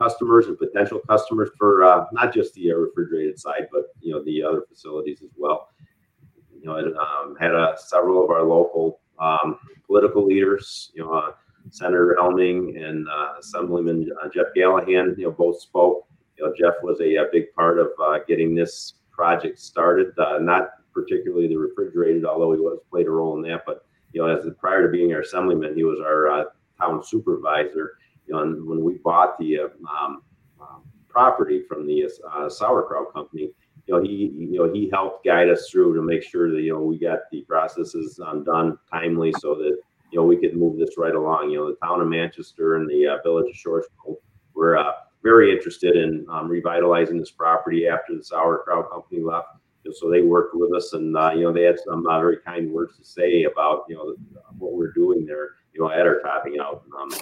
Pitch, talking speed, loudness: 90 Hz, 205 wpm, -21 LUFS